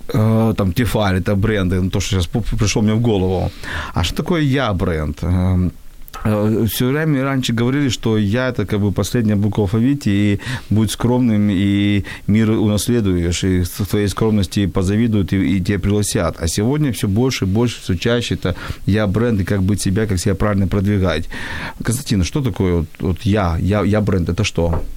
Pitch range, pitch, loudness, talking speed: 95-115 Hz, 105 Hz, -18 LUFS, 175 wpm